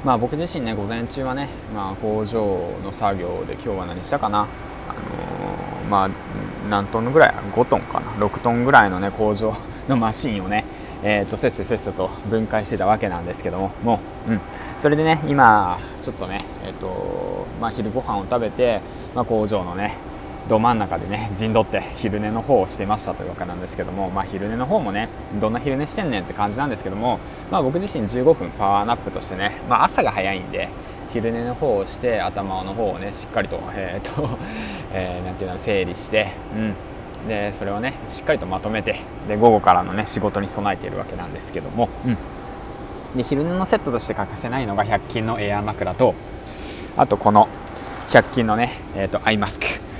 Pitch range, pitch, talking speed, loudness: 100-120 Hz, 110 Hz, 360 characters per minute, -22 LUFS